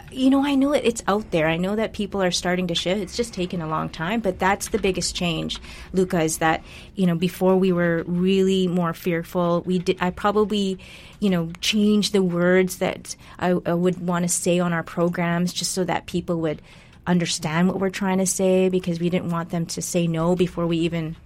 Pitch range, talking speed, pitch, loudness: 170-190 Hz, 225 wpm, 180 Hz, -22 LUFS